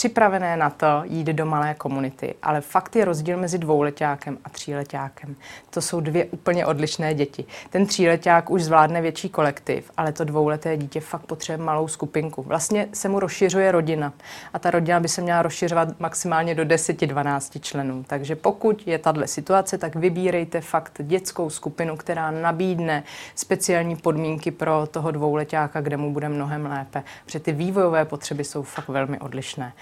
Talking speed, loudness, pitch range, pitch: 165 wpm, -23 LUFS, 150-175 Hz, 160 Hz